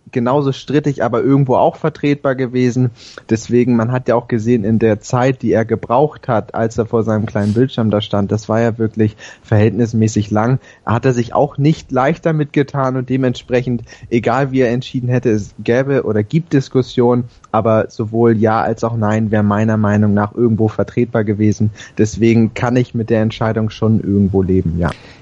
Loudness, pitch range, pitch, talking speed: -15 LUFS, 110-125 Hz, 115 Hz, 185 wpm